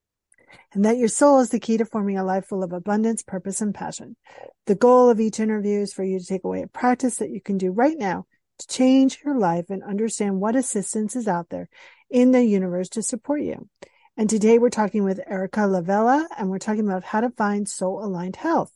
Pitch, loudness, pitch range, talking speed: 215 Hz, -22 LUFS, 195-245 Hz, 225 wpm